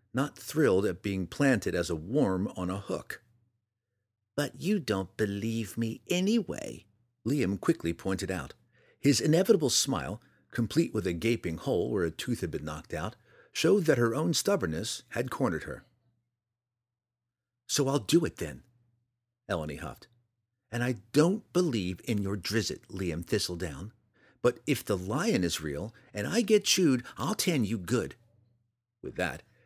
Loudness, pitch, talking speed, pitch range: -30 LUFS, 115 Hz, 155 wpm, 100-130 Hz